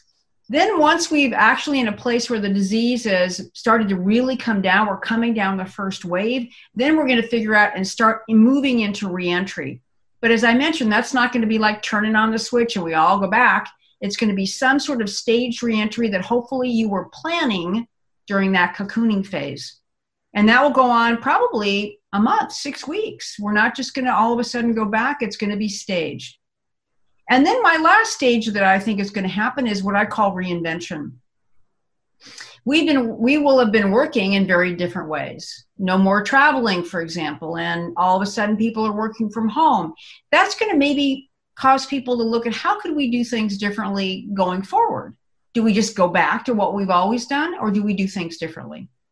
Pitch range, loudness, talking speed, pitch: 195-245 Hz, -19 LUFS, 210 wpm, 220 Hz